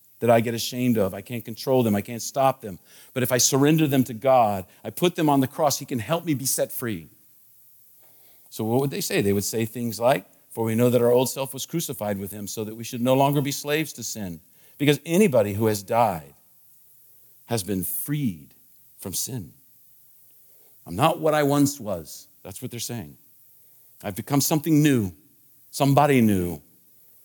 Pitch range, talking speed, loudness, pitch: 110-140 Hz, 200 wpm, -23 LUFS, 125 Hz